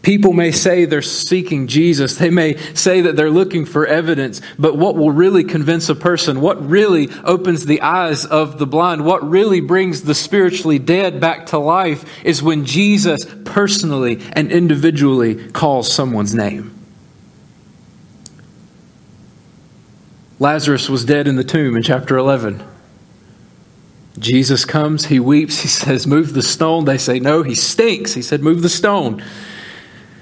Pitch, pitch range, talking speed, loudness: 155 Hz, 140-175 Hz, 150 wpm, -14 LUFS